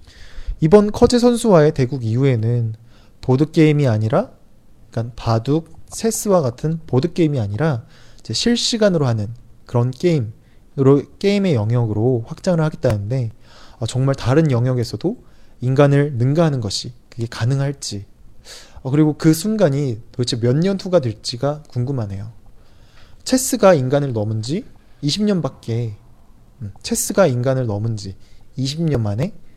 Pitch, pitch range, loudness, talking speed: 130 Hz, 115-160 Hz, -18 LUFS, 280 characters per minute